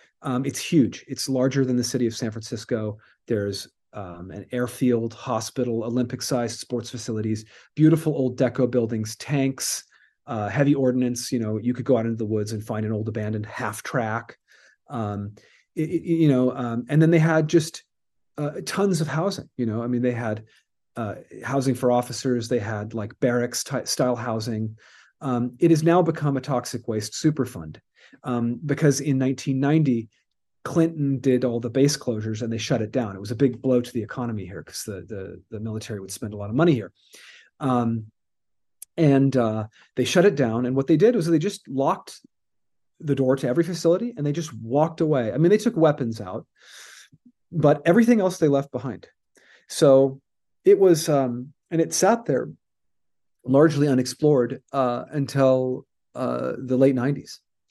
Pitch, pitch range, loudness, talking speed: 125 Hz, 115-145 Hz, -23 LUFS, 180 wpm